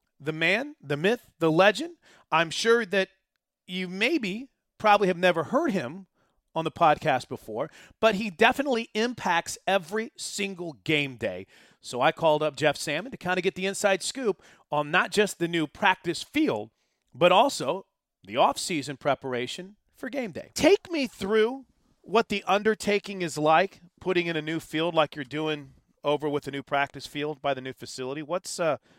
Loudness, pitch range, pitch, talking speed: -26 LUFS, 150-205 Hz, 175 Hz, 175 wpm